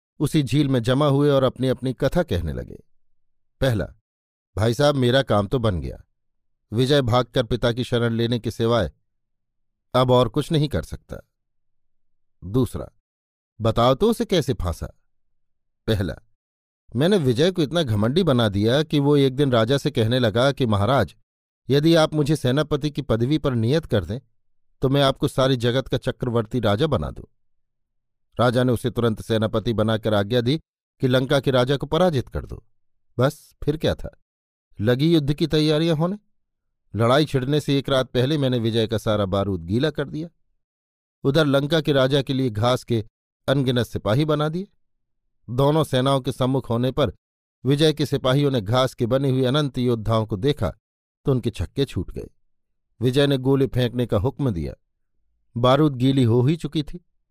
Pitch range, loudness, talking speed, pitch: 110-140 Hz, -21 LUFS, 170 wpm, 125 Hz